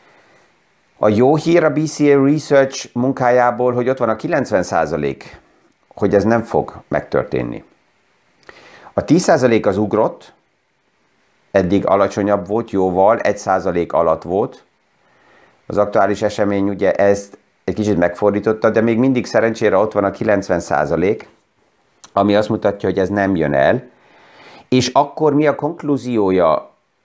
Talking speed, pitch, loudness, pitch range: 125 wpm, 110 Hz, -16 LUFS, 100-125 Hz